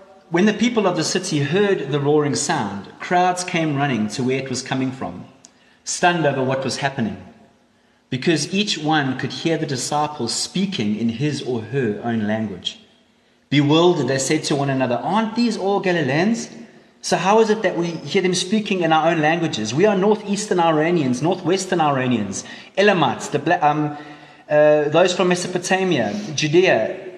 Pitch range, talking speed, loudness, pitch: 135-190 Hz, 160 wpm, -19 LUFS, 160 Hz